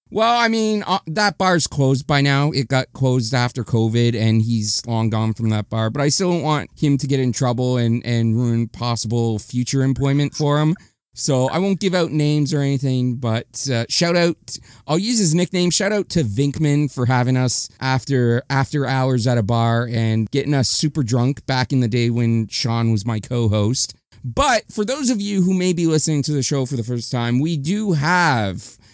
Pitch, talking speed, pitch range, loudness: 130 Hz, 205 wpm, 120-155 Hz, -19 LUFS